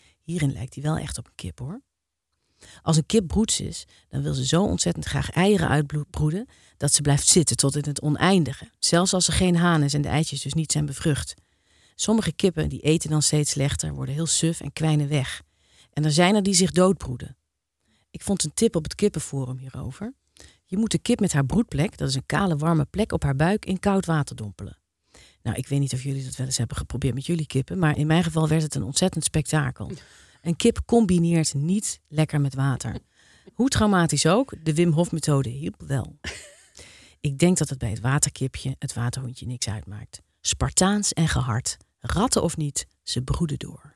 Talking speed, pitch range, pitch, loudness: 205 wpm, 130-170 Hz, 150 Hz, -23 LUFS